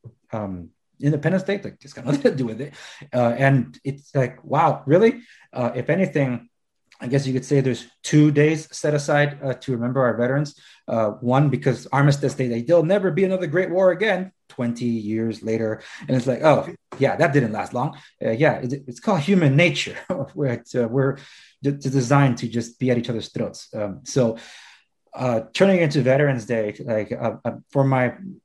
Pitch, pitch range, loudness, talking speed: 135 Hz, 120-150 Hz, -21 LUFS, 190 wpm